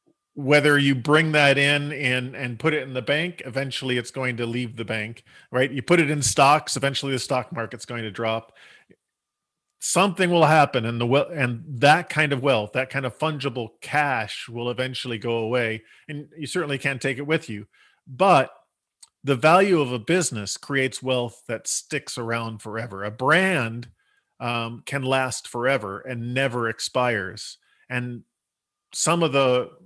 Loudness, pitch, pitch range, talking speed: -23 LUFS, 130 Hz, 120-145 Hz, 170 wpm